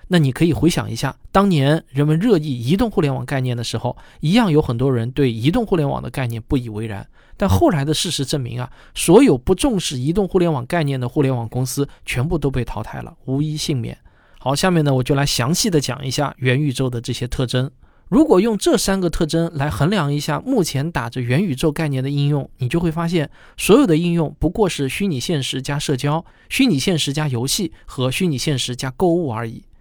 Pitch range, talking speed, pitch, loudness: 130-170 Hz, 330 characters per minute, 145 Hz, -19 LUFS